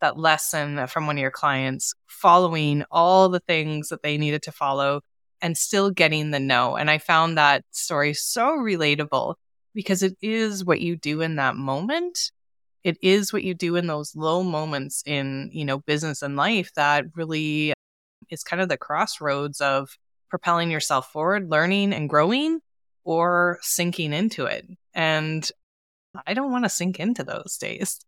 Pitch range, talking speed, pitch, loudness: 145-185 Hz, 170 wpm, 160 Hz, -23 LUFS